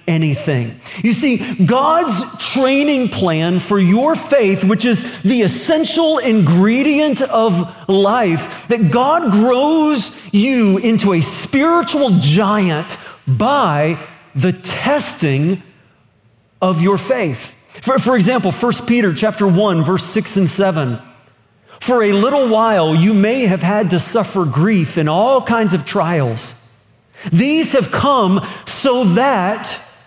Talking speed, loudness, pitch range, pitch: 125 wpm, -14 LUFS, 165-235 Hz, 195 Hz